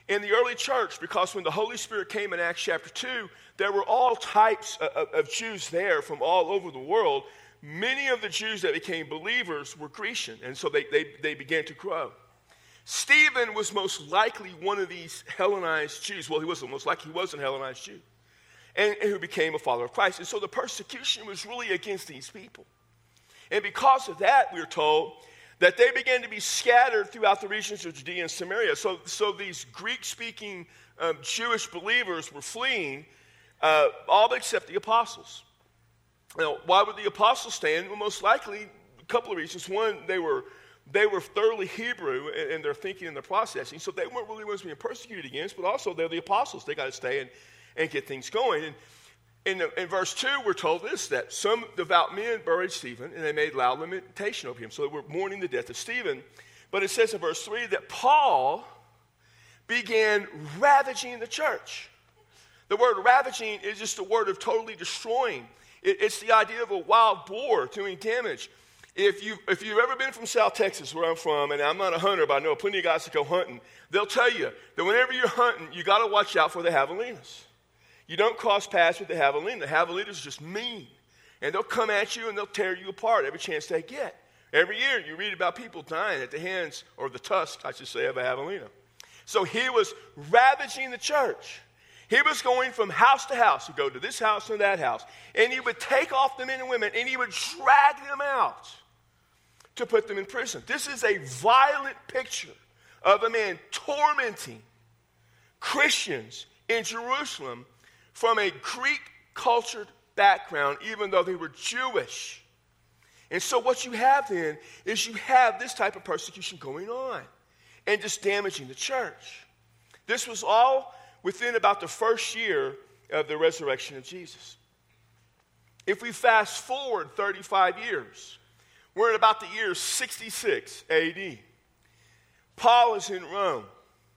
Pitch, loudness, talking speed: 235 Hz, -26 LUFS, 190 wpm